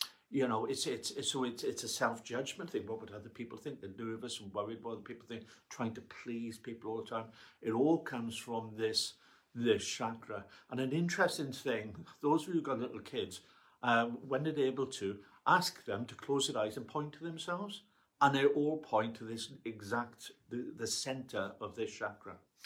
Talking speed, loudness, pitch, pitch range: 205 wpm, -37 LUFS, 120 Hz, 115-140 Hz